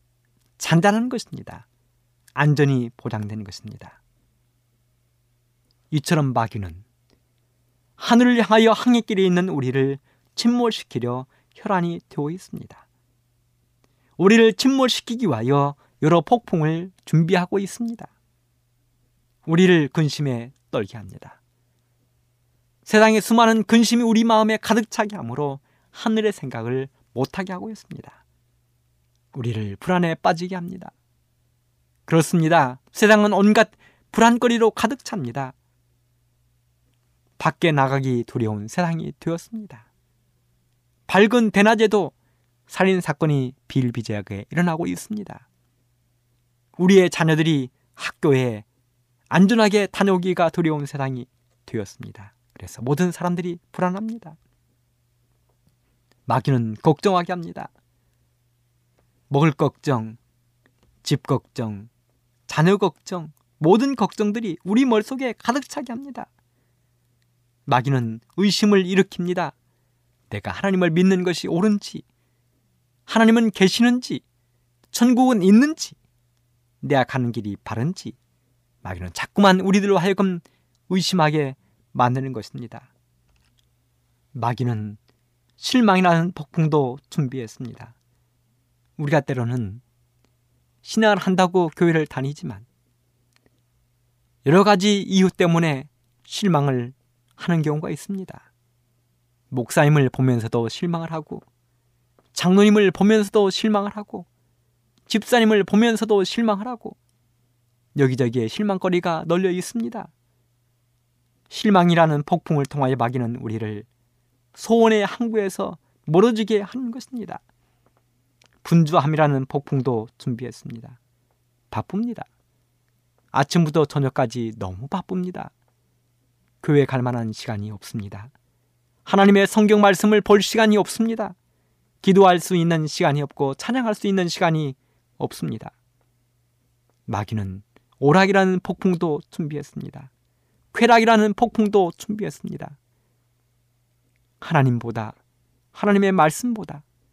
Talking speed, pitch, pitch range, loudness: 255 characters per minute, 135 Hz, 120-185 Hz, -20 LUFS